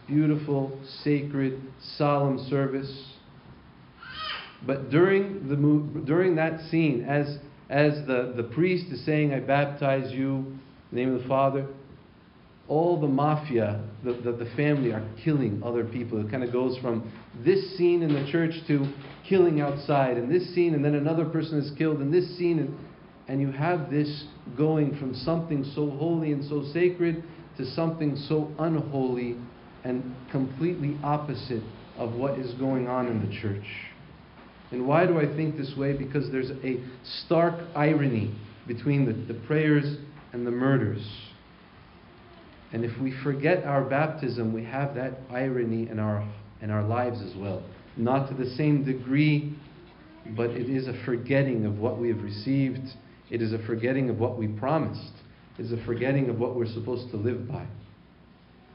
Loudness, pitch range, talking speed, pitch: -27 LUFS, 120-150 Hz, 165 wpm, 135 Hz